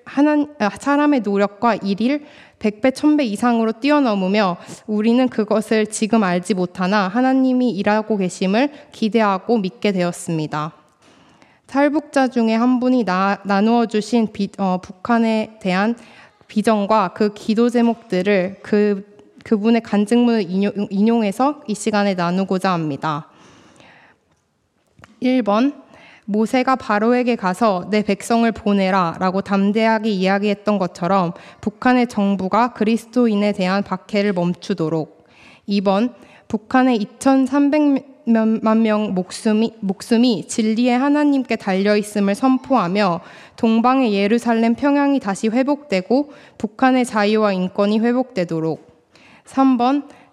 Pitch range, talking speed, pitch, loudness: 200-245 Hz, 260 characters per minute, 220 Hz, -18 LUFS